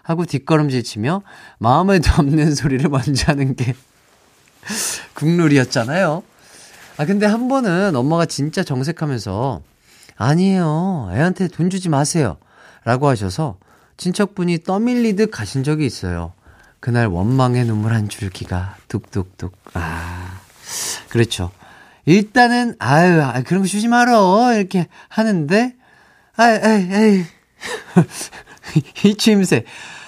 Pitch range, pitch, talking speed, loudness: 120-190 Hz, 155 Hz, 245 characters per minute, -17 LUFS